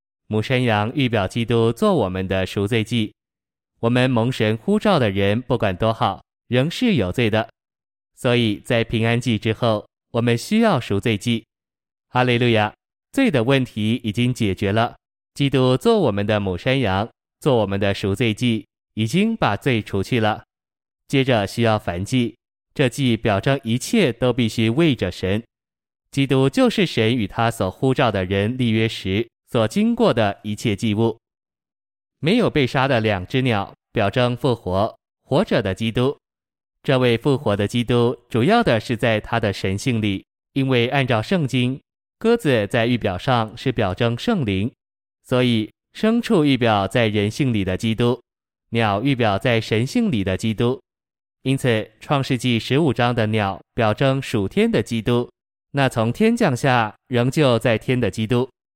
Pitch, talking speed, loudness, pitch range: 120 Hz, 230 characters per minute, -20 LUFS, 110-130 Hz